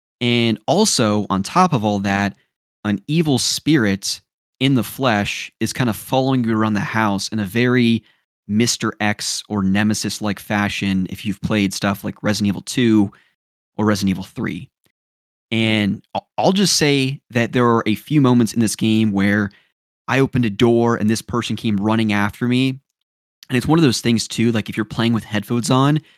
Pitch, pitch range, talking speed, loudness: 110 Hz, 105-125 Hz, 185 wpm, -18 LUFS